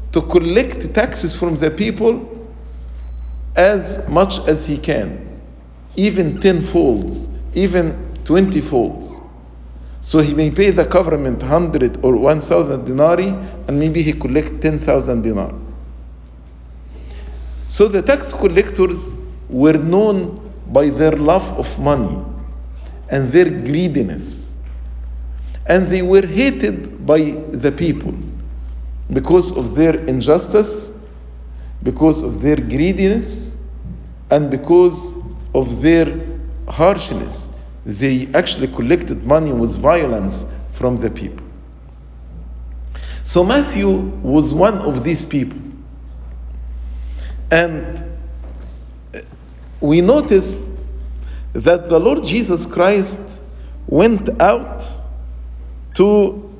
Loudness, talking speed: -16 LUFS, 100 wpm